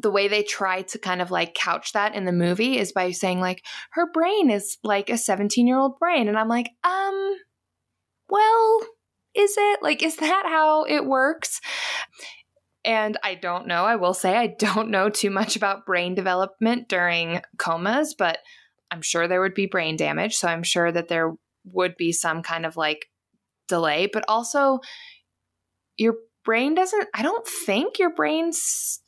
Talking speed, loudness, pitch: 175 wpm, -23 LUFS, 215 Hz